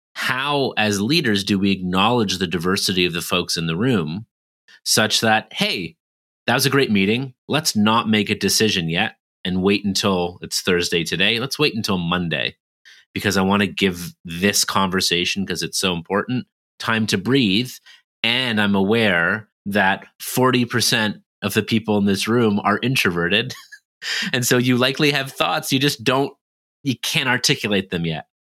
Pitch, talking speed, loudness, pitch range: 105 Hz, 165 wpm, -19 LUFS, 95-125 Hz